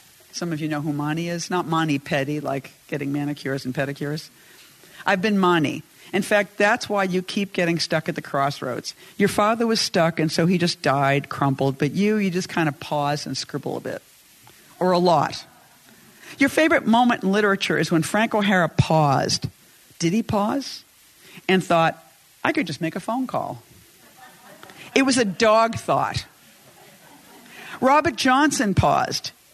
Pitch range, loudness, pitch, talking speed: 150-205 Hz, -22 LUFS, 170 Hz, 170 wpm